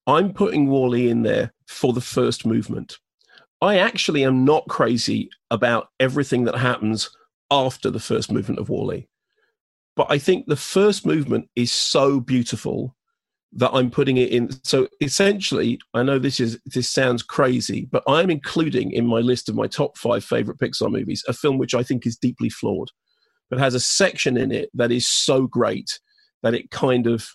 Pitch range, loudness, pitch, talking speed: 120-145 Hz, -21 LUFS, 130 Hz, 180 wpm